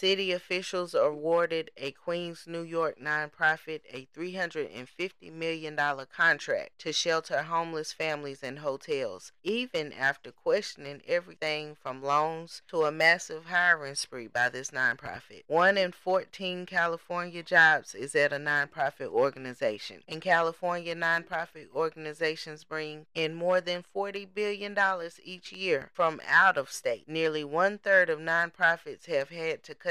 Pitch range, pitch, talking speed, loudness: 150-180 Hz, 165 Hz, 135 wpm, -29 LUFS